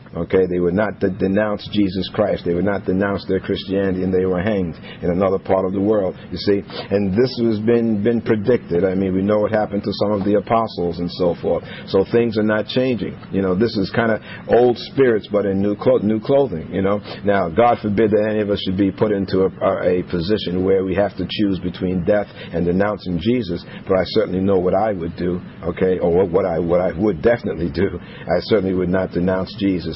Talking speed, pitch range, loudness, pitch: 230 wpm, 95-105 Hz, -19 LUFS, 100 Hz